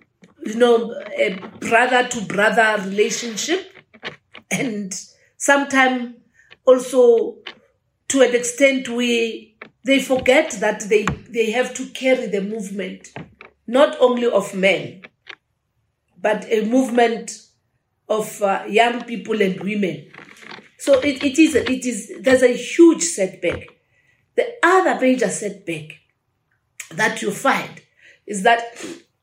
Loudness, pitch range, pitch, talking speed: -18 LUFS, 205-255 Hz, 230 Hz, 115 wpm